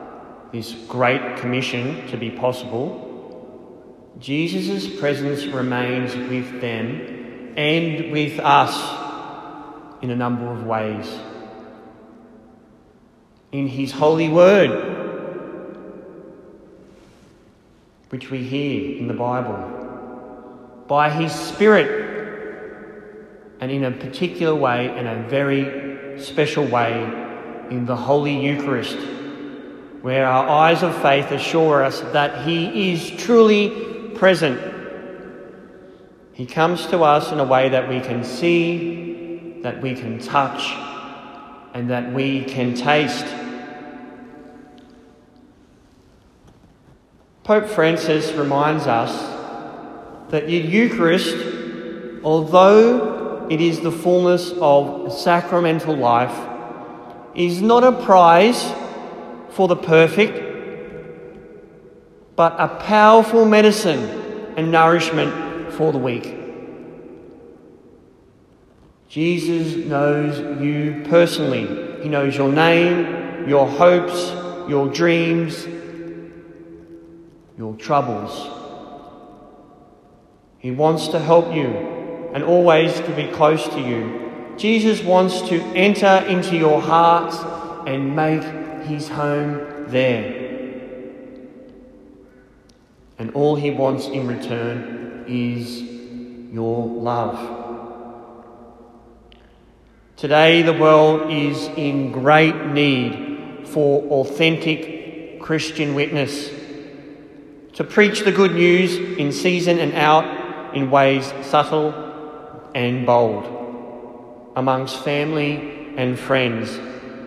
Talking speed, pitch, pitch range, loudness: 95 wpm, 145 Hz, 125-165 Hz, -18 LUFS